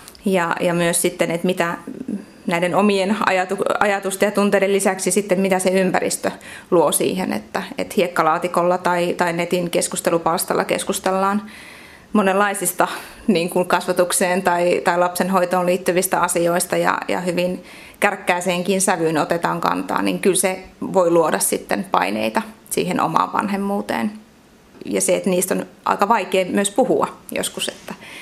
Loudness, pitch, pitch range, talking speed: -19 LUFS, 185 Hz, 175-200 Hz, 135 wpm